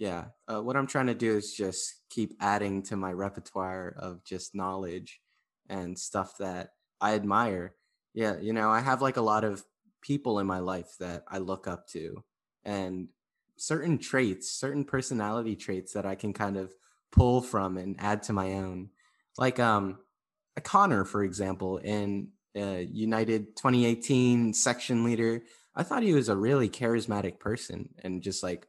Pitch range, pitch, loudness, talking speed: 95-120 Hz, 105 Hz, -30 LUFS, 170 wpm